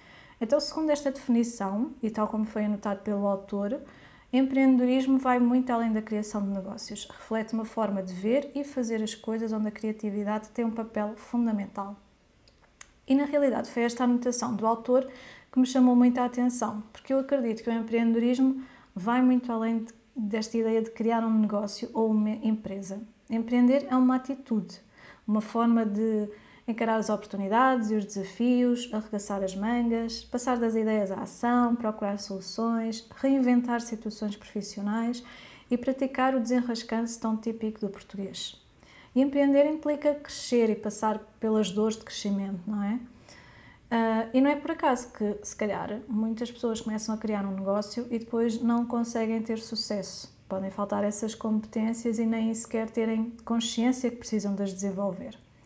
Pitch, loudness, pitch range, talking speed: 225 Hz, -28 LUFS, 210-245 Hz, 160 wpm